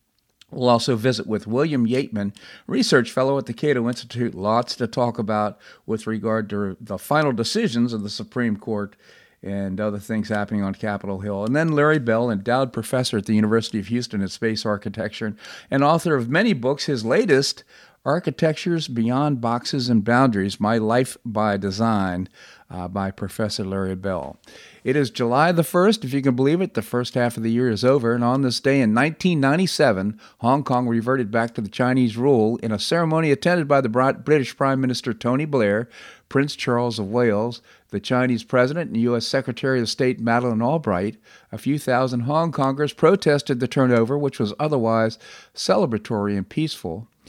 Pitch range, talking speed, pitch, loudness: 110-135 Hz, 175 wpm, 120 Hz, -21 LUFS